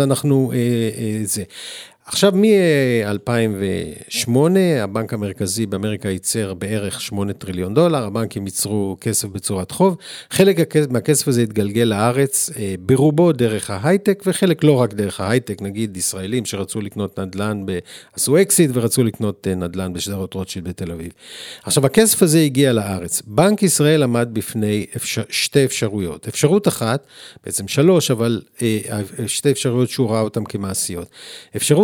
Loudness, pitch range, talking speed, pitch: -18 LUFS, 100-140 Hz, 135 wpm, 115 Hz